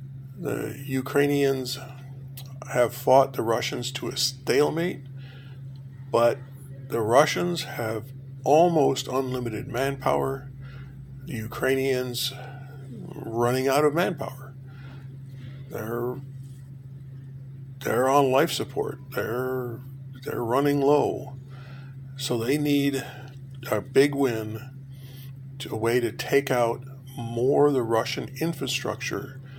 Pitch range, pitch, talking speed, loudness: 130-135 Hz, 135 Hz, 95 wpm, -25 LUFS